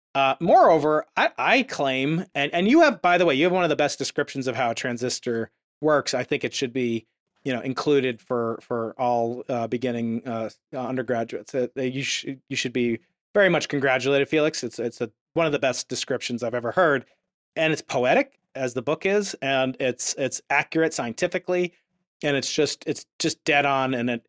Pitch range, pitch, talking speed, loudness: 125-155 Hz, 135 Hz, 205 wpm, -24 LUFS